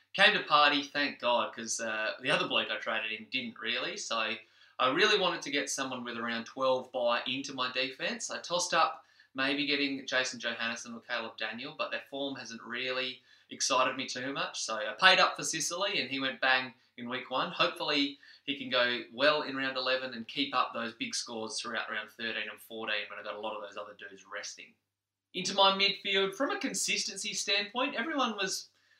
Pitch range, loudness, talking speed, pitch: 115-160 Hz, -31 LUFS, 205 wpm, 130 Hz